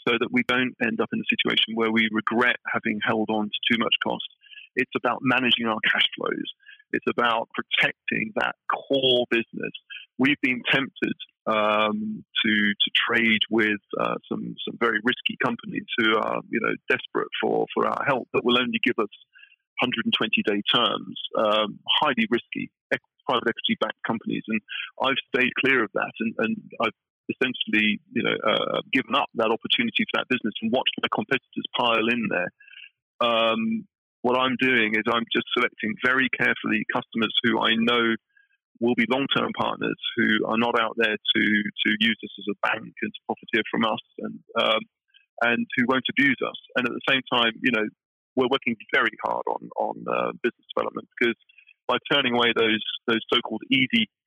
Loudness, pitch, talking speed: -24 LUFS, 120 Hz, 180 wpm